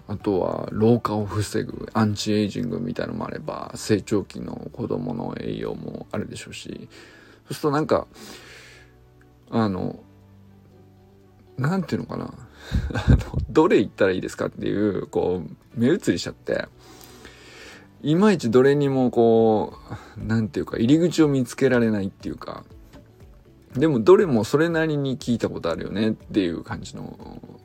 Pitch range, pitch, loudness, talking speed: 100-125 Hz, 110 Hz, -23 LUFS, 315 characters per minute